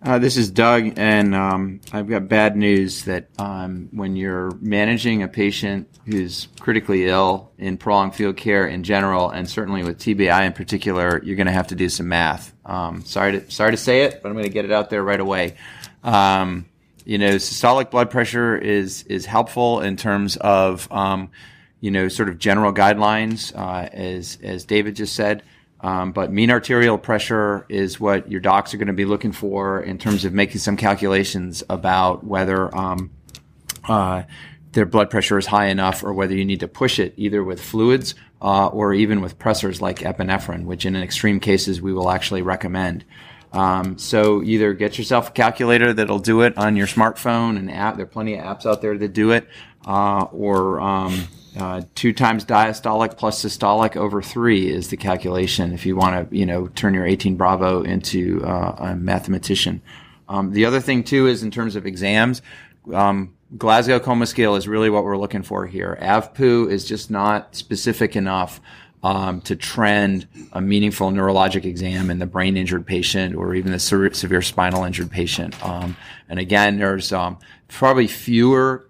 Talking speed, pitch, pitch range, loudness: 185 wpm, 100 Hz, 95-110 Hz, -19 LUFS